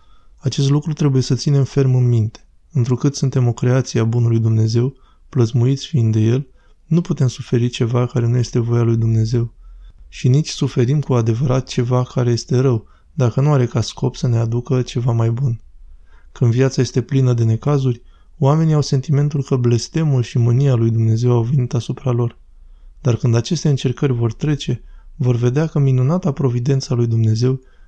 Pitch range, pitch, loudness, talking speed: 115-135 Hz, 125 Hz, -17 LUFS, 175 wpm